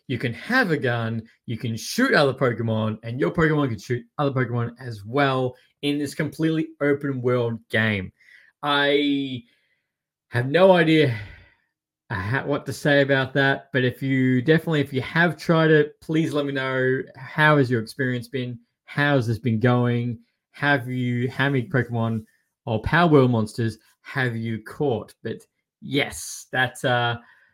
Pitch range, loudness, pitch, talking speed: 120-145 Hz, -22 LUFS, 130 Hz, 160 wpm